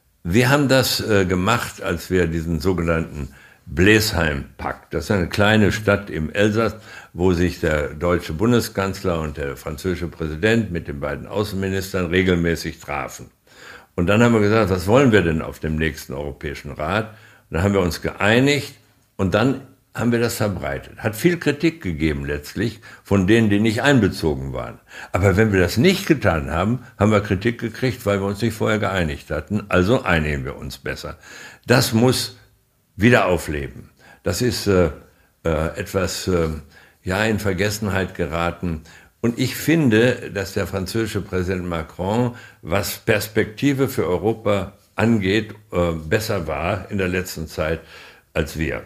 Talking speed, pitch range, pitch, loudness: 155 wpm, 85-110 Hz, 100 Hz, -20 LUFS